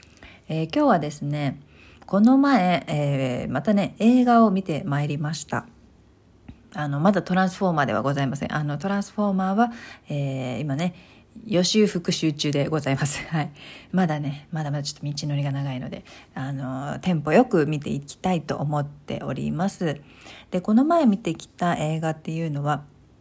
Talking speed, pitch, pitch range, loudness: 355 characters per minute, 155 Hz, 140-190 Hz, -24 LUFS